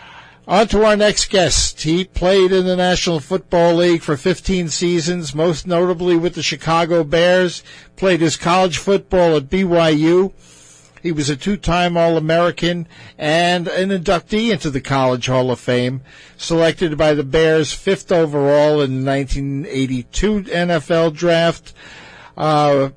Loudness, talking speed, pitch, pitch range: -16 LUFS, 140 wpm, 170 Hz, 150-180 Hz